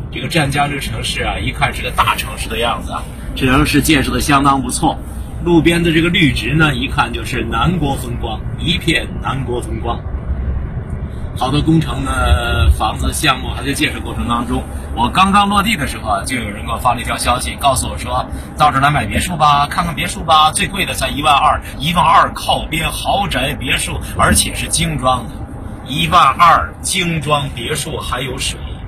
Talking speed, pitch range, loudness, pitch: 285 characters per minute, 110-160 Hz, -15 LUFS, 140 Hz